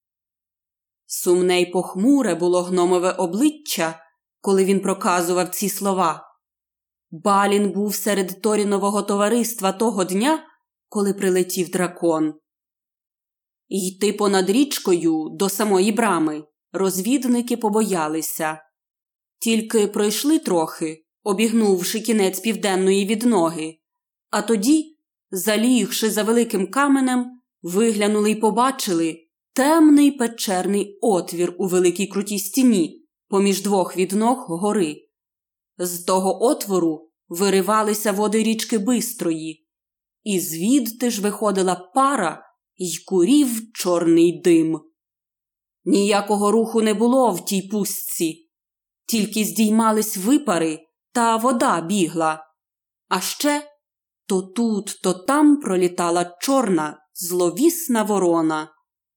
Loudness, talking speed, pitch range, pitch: -20 LUFS, 95 wpm, 175-230 Hz, 200 Hz